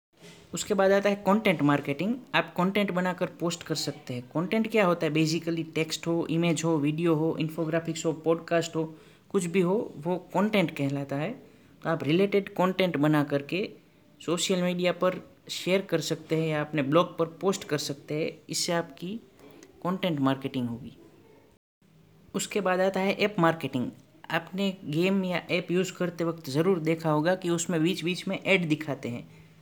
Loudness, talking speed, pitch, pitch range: -28 LUFS, 170 wpm, 170 Hz, 155-185 Hz